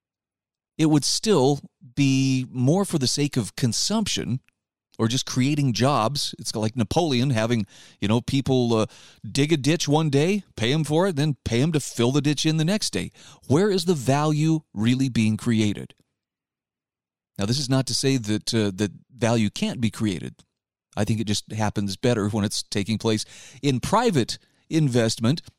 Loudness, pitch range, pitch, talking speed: -23 LUFS, 110-150 Hz, 130 Hz, 175 wpm